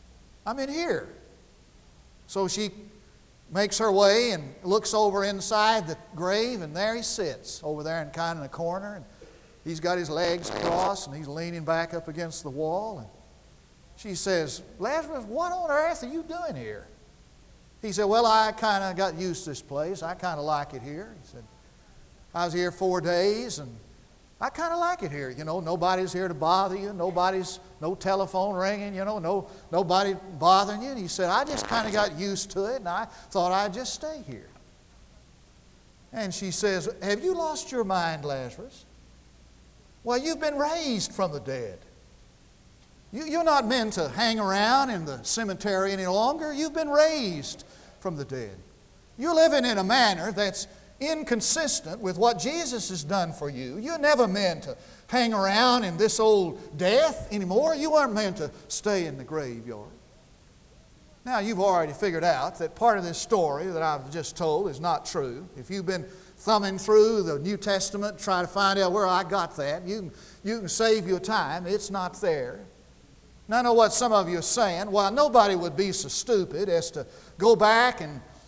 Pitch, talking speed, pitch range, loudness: 195 Hz, 190 wpm, 170-220 Hz, -26 LUFS